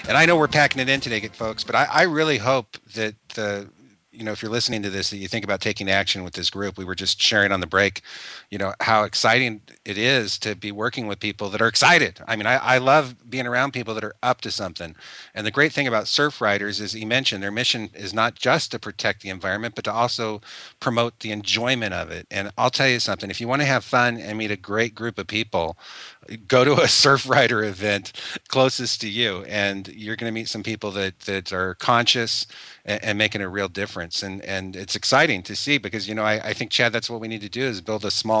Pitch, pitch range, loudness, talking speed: 110 Hz, 100-120 Hz, -22 LUFS, 250 wpm